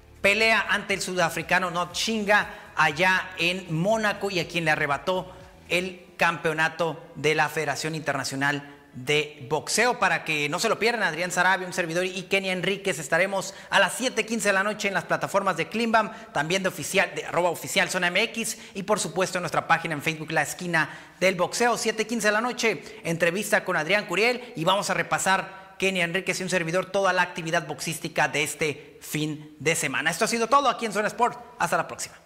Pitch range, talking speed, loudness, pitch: 160-200 Hz, 195 wpm, -25 LUFS, 180 Hz